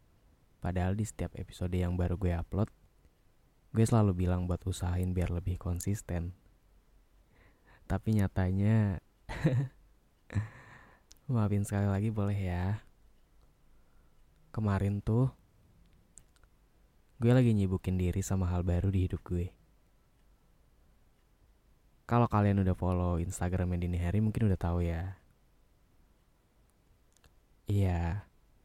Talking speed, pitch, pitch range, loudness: 100 wpm, 95 Hz, 90-105 Hz, -32 LUFS